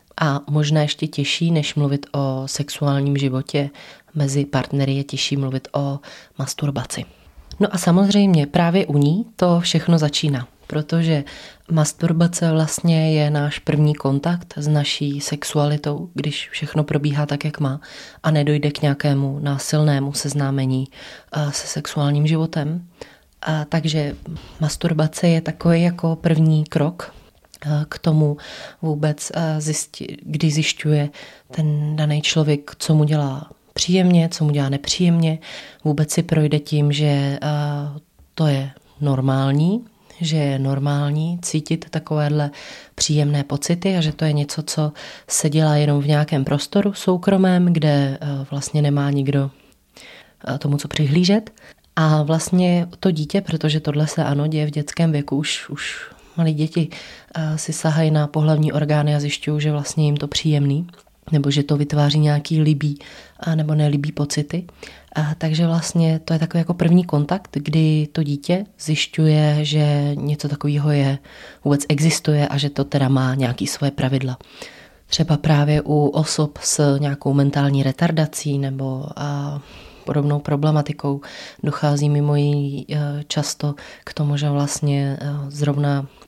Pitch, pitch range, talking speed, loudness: 150 Hz, 145-160 Hz, 135 wpm, -20 LUFS